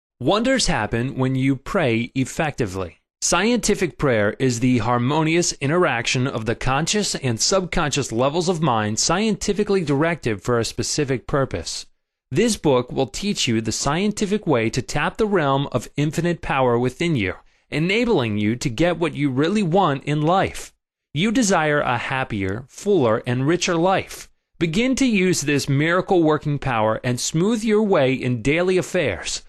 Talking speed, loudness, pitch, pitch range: 155 wpm, -20 LUFS, 145 Hz, 125-180 Hz